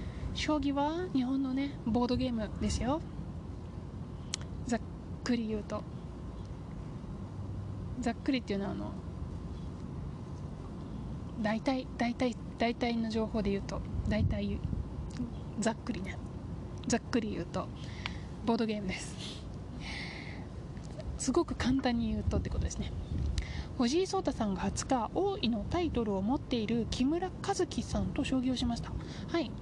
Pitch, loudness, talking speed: 235 Hz, -35 LUFS, 250 characters per minute